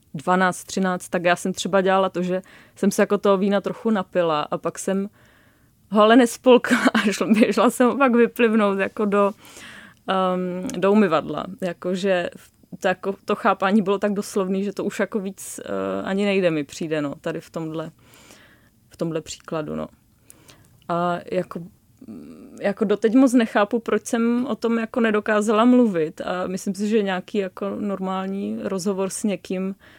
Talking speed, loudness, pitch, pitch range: 165 wpm, -21 LUFS, 195 Hz, 180-215 Hz